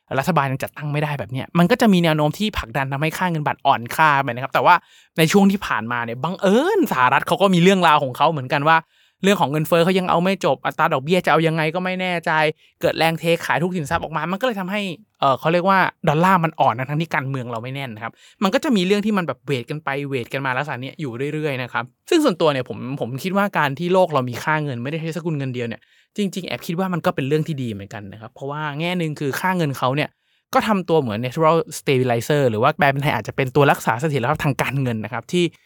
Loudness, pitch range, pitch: -20 LUFS, 135-175 Hz, 155 Hz